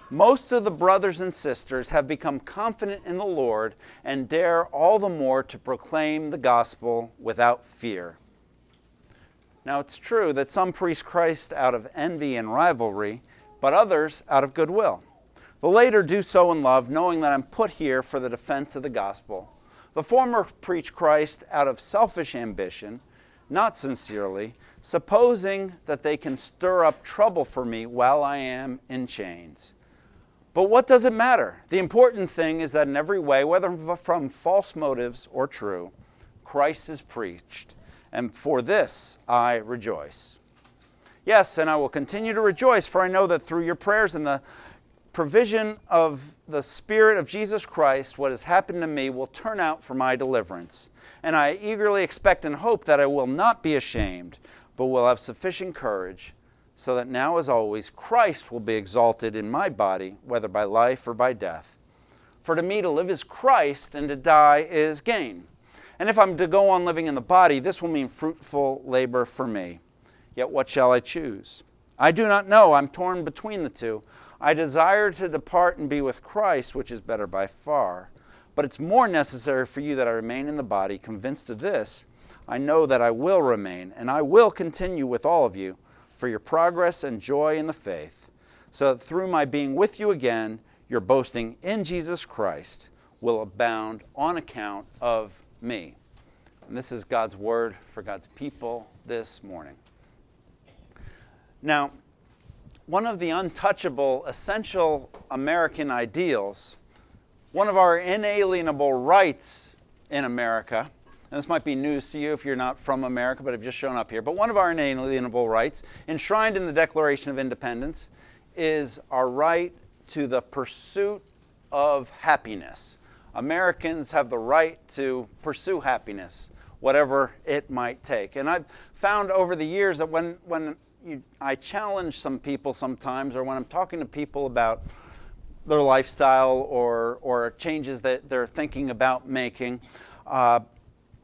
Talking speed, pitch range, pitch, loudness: 170 wpm, 120-175 Hz, 140 Hz, -24 LUFS